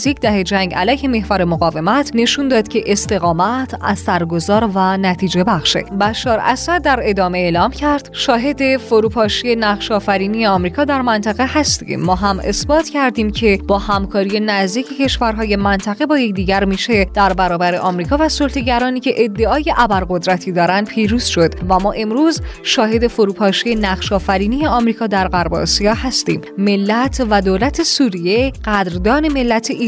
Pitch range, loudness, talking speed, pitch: 195-250 Hz, -15 LUFS, 140 wpm, 215 Hz